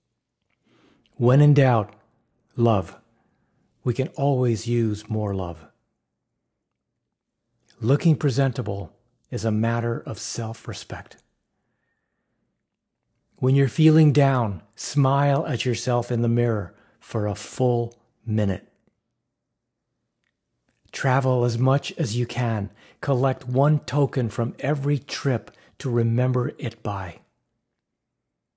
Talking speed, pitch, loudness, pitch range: 100 wpm, 120 Hz, -23 LUFS, 110-135 Hz